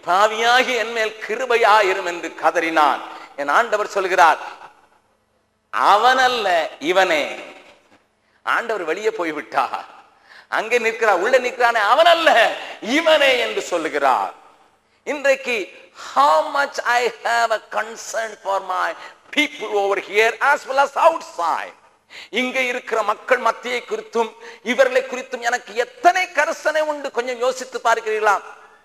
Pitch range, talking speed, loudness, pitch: 220-295 Hz, 110 wpm, -19 LUFS, 245 Hz